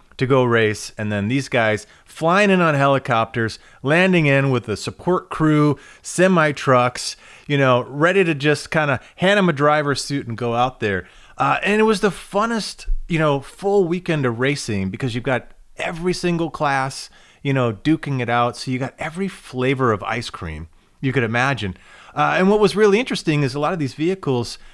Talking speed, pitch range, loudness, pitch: 195 wpm, 120-170 Hz, -19 LUFS, 140 Hz